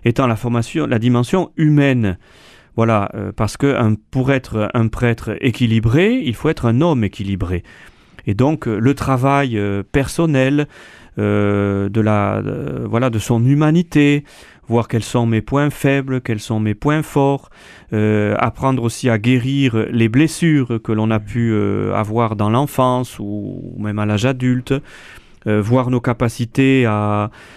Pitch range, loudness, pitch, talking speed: 110-135 Hz, -17 LUFS, 120 Hz, 155 wpm